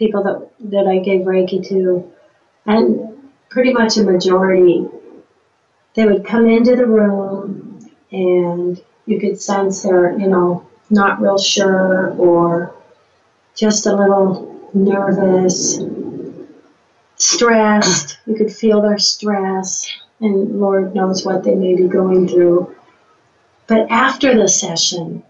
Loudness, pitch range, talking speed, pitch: -14 LUFS, 185-215 Hz, 125 wpm, 195 Hz